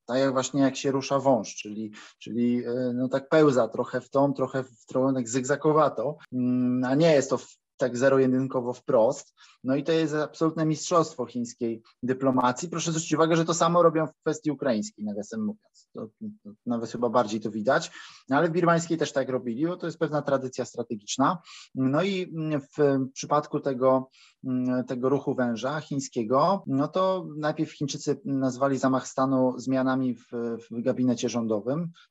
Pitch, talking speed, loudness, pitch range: 135 Hz, 170 wpm, -26 LUFS, 125-155 Hz